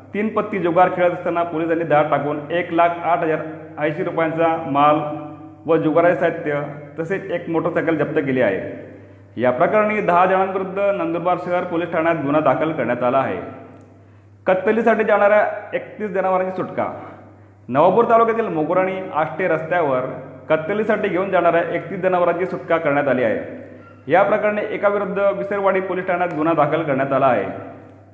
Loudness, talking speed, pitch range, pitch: -19 LUFS, 145 wpm, 150-190 Hz, 170 Hz